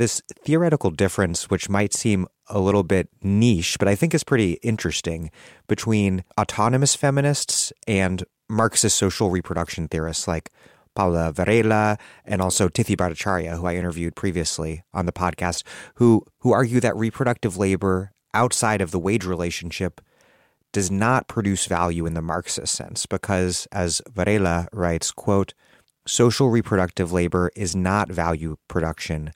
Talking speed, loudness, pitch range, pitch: 140 wpm, -22 LUFS, 90-115 Hz, 95 Hz